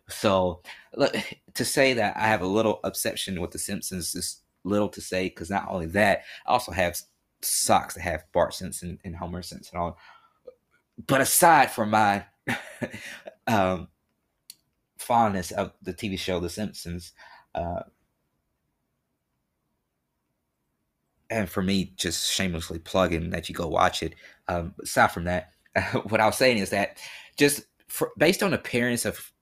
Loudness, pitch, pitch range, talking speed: -26 LUFS, 95 Hz, 90-110 Hz, 150 wpm